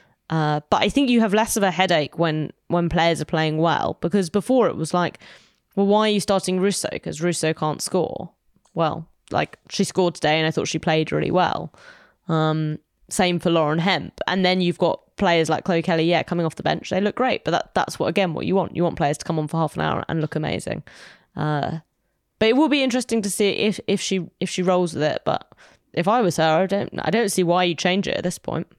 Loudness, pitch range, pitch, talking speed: -22 LUFS, 160-200 Hz, 175 Hz, 245 wpm